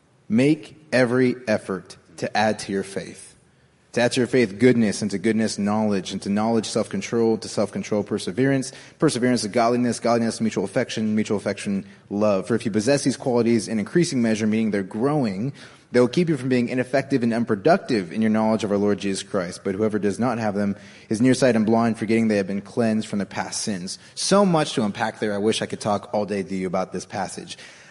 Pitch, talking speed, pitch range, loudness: 115 Hz, 220 wpm, 105-125 Hz, -22 LUFS